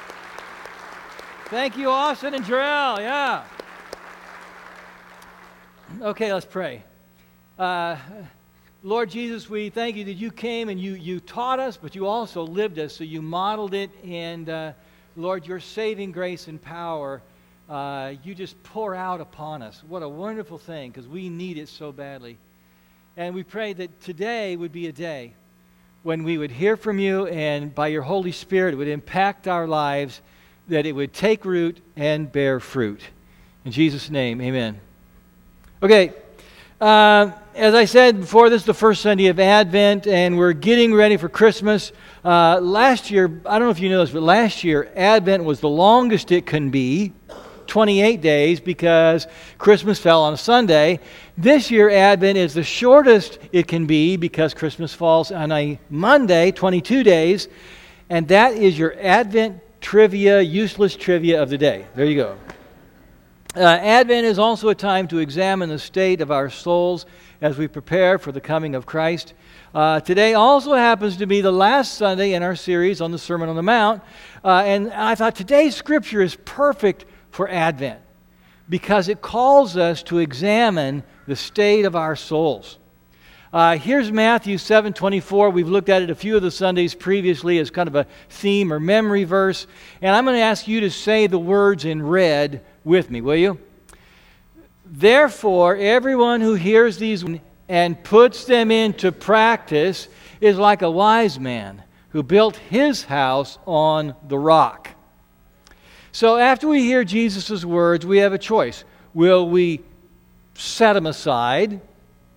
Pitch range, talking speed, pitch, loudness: 155-210 Hz, 165 wpm, 180 Hz, -17 LUFS